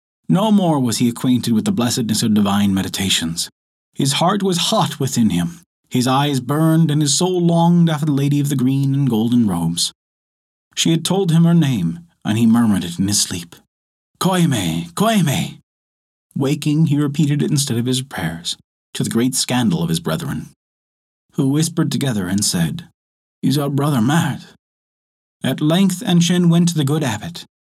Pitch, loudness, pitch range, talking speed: 135 Hz, -17 LUFS, 100-160 Hz, 175 wpm